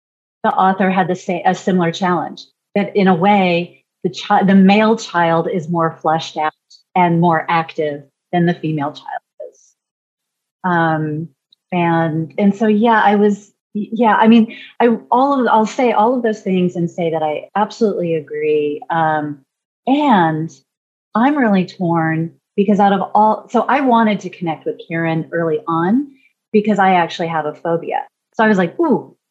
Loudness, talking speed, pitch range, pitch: -16 LUFS, 170 wpm, 165-215 Hz, 185 Hz